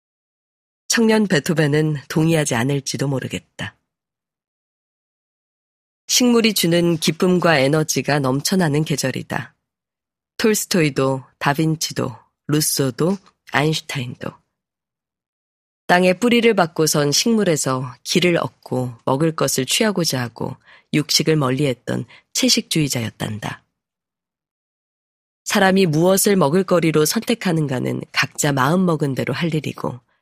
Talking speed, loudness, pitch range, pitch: 250 characters per minute, -18 LUFS, 135-185 Hz, 155 Hz